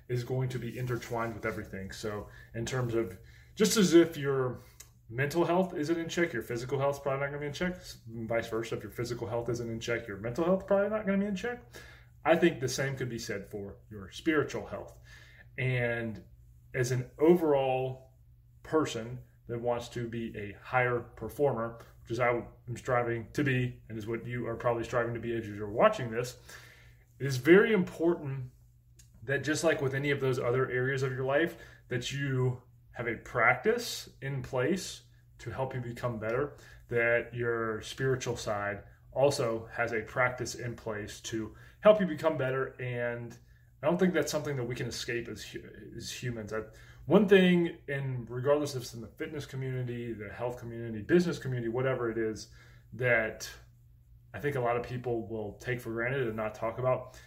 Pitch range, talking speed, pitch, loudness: 115-135 Hz, 190 wpm, 120 Hz, -31 LUFS